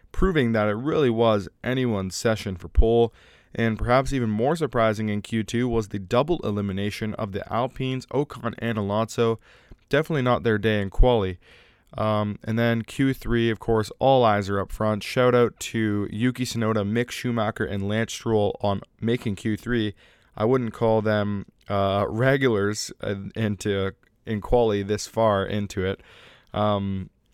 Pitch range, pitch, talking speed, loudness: 105-120 Hz, 110 Hz, 155 wpm, -24 LUFS